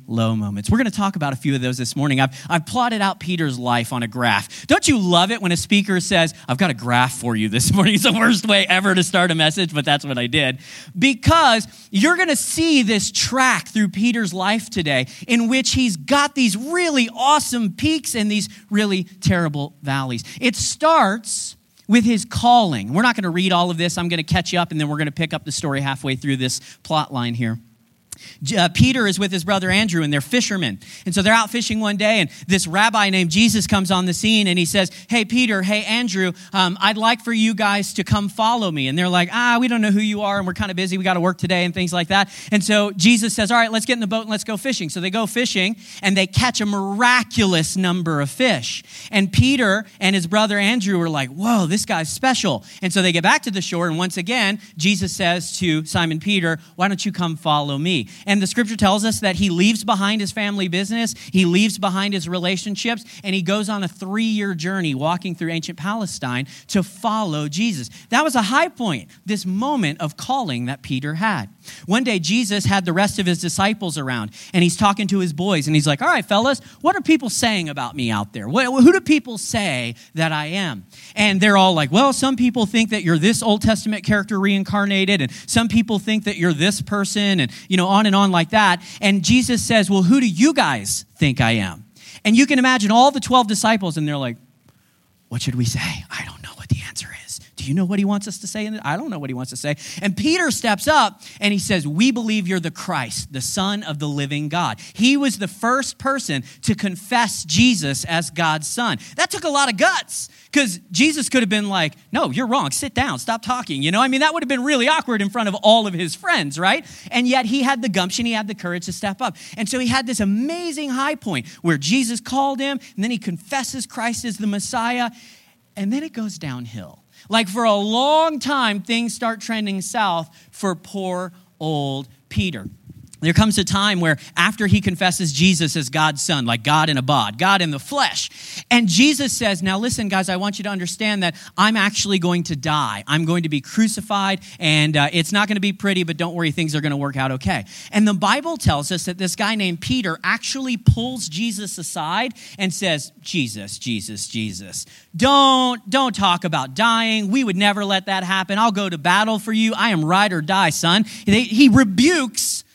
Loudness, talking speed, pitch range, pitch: -19 LUFS, 230 wpm, 170-225 Hz, 195 Hz